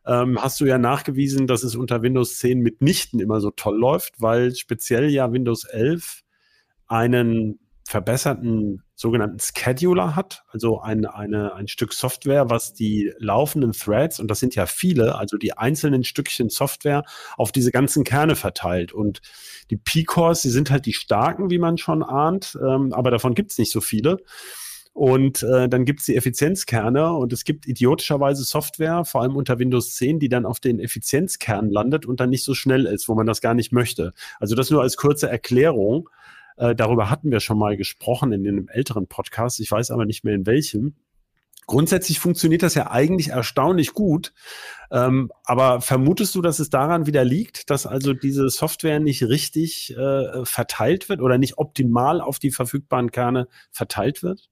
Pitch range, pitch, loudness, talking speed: 115-145 Hz, 130 Hz, -21 LUFS, 175 wpm